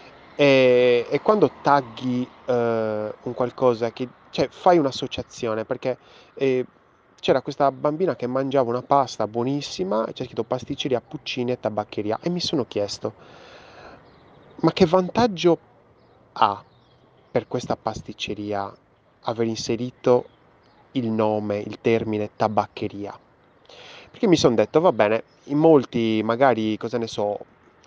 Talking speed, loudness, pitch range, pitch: 125 wpm, -23 LUFS, 110-135 Hz, 125 Hz